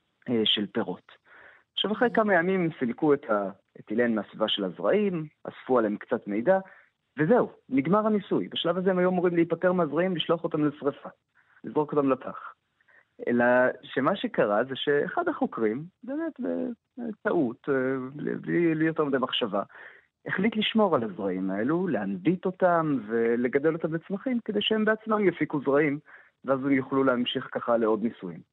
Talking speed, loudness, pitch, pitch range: 140 wpm, -27 LUFS, 160 Hz, 130-200 Hz